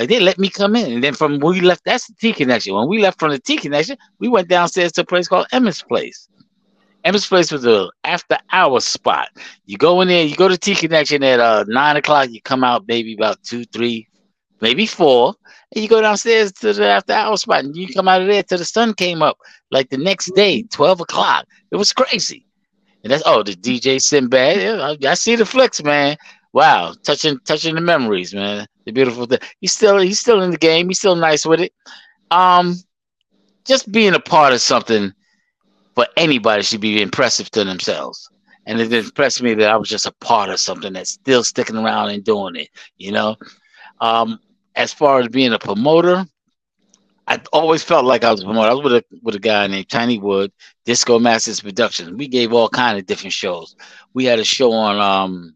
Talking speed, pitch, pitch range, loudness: 215 wpm, 150 Hz, 115-190 Hz, -15 LUFS